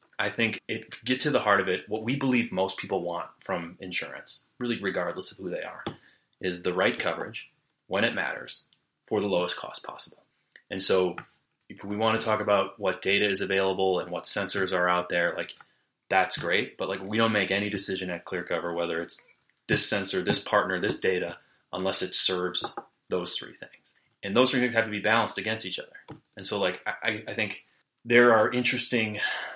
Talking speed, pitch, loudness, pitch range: 200 wpm, 100 Hz, -27 LUFS, 95-115 Hz